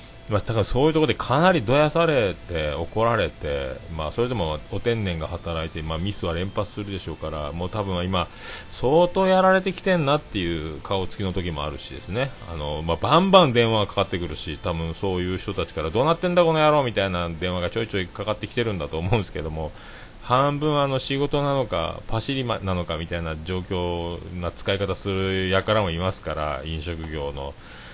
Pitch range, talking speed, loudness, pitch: 85-125 Hz, 405 characters per minute, -24 LUFS, 95 Hz